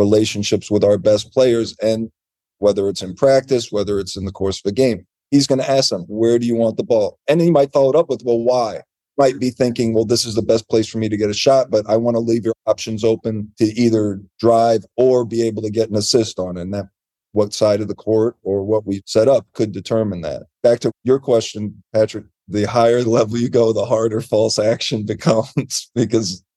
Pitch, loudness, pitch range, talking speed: 110 Hz, -17 LUFS, 105-120 Hz, 235 wpm